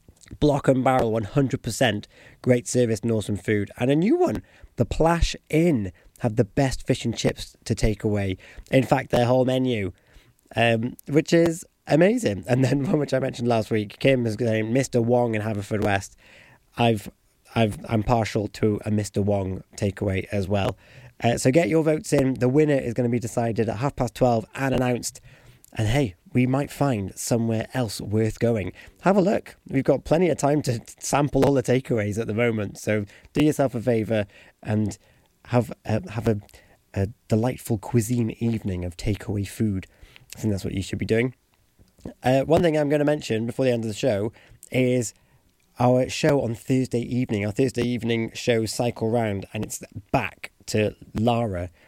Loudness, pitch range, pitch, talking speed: -24 LUFS, 110-130 Hz, 120 Hz, 185 wpm